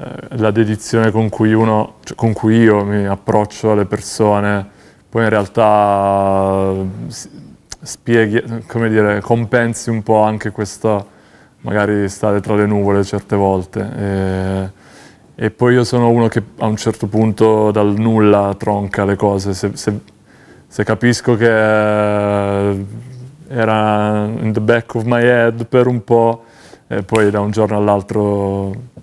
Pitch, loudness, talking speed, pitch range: 105 Hz, -15 LUFS, 140 wpm, 100-115 Hz